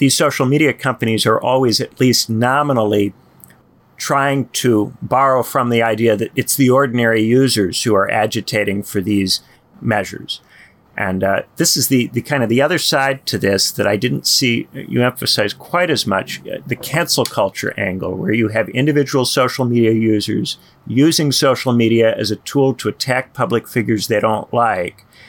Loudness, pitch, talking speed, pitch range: -16 LUFS, 120 Hz, 170 wpm, 105-135 Hz